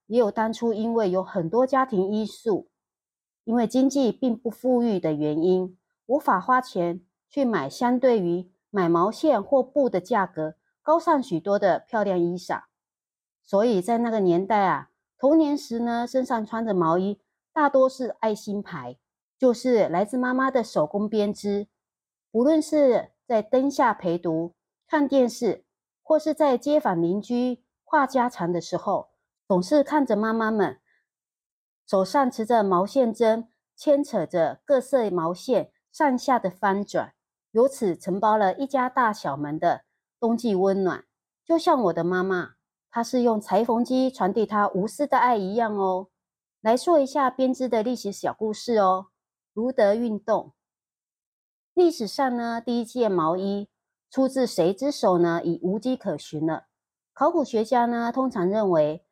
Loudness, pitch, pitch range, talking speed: -24 LUFS, 225 Hz, 190-255 Hz, 220 characters per minute